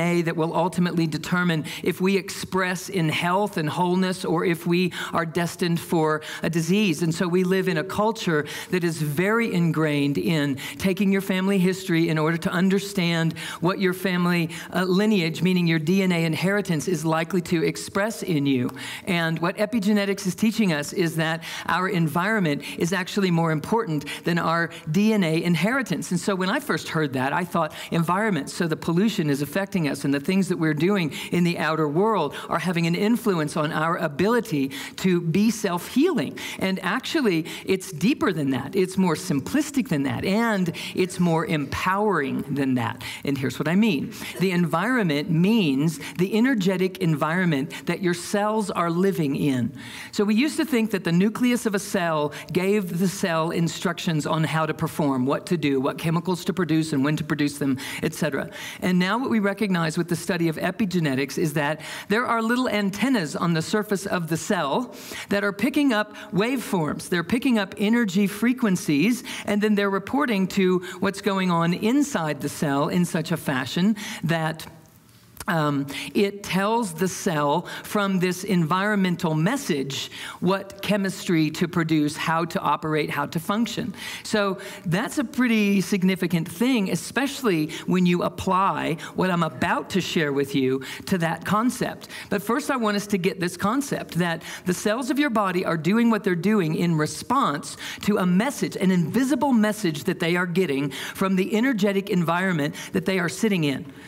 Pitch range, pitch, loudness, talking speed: 160-205 Hz, 180 Hz, -23 LUFS, 175 wpm